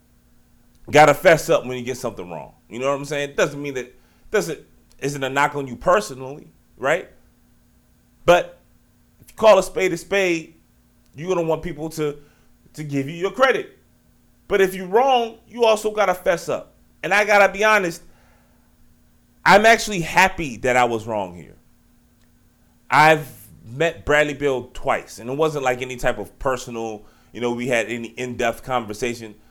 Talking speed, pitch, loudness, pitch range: 180 wpm, 140 Hz, -20 LUFS, 120-170 Hz